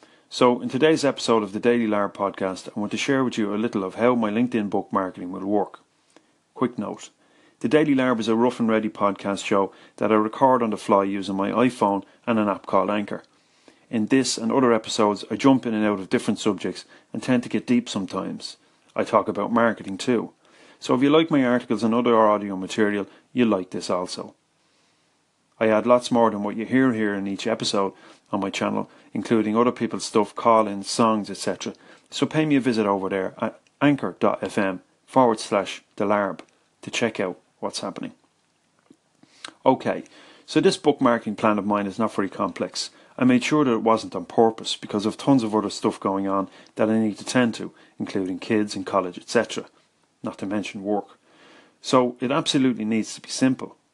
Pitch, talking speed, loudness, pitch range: 110 Hz, 195 wpm, -23 LUFS, 100-125 Hz